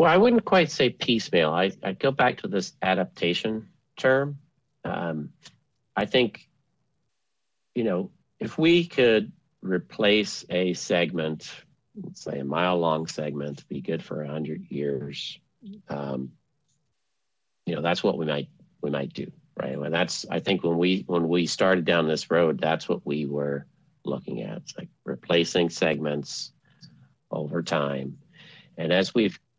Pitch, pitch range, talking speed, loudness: 85 Hz, 75-115 Hz, 150 wpm, -26 LUFS